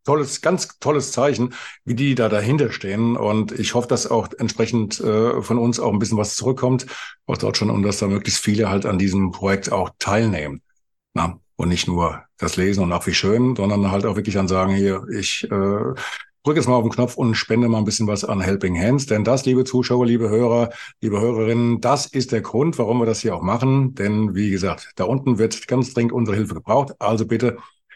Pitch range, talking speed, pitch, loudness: 100-125 Hz, 220 wpm, 110 Hz, -20 LUFS